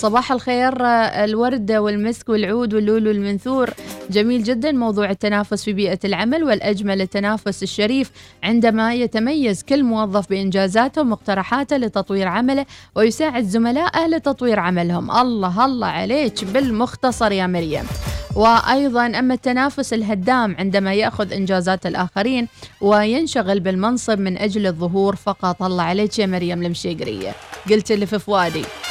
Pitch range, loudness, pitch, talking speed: 200-245 Hz, -19 LUFS, 215 Hz, 120 wpm